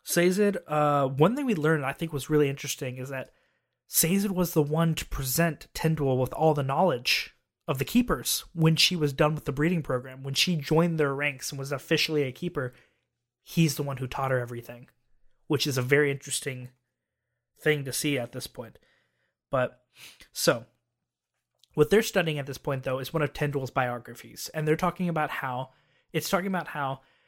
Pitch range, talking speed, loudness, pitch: 130-160 Hz, 190 wpm, -27 LUFS, 145 Hz